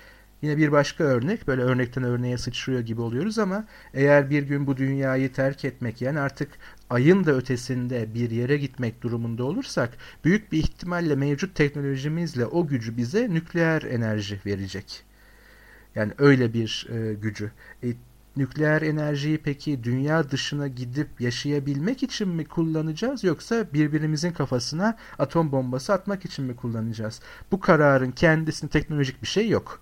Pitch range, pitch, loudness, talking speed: 125-160 Hz, 140 Hz, -25 LUFS, 145 wpm